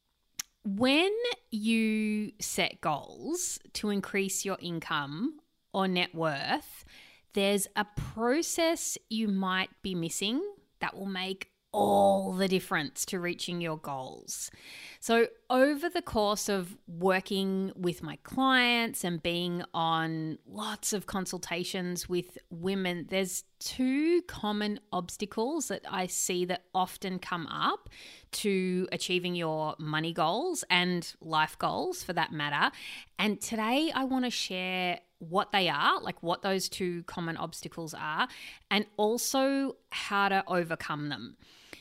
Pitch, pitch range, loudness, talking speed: 190 Hz, 175-220 Hz, -31 LUFS, 130 wpm